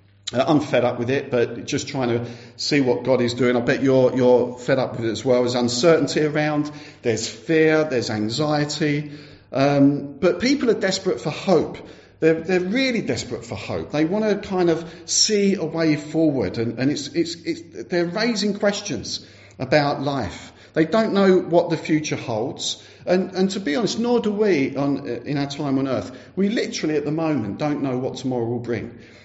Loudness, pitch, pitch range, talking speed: -21 LUFS, 145 Hz, 125-170 Hz, 195 wpm